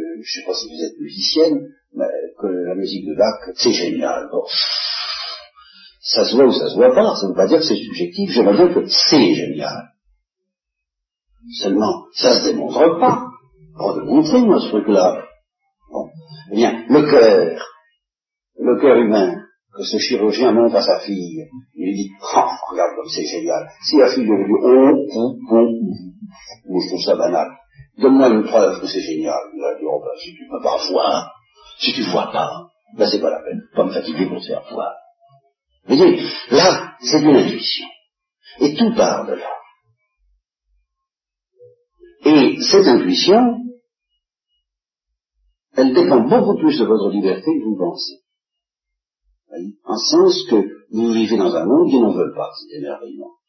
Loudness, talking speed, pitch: -16 LUFS, 175 wpm, 265 Hz